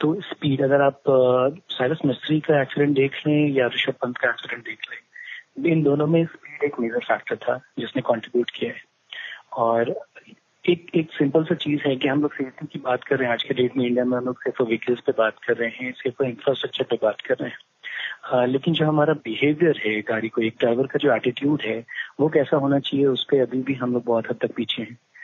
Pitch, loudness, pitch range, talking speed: 135 Hz, -23 LUFS, 125-150 Hz, 230 wpm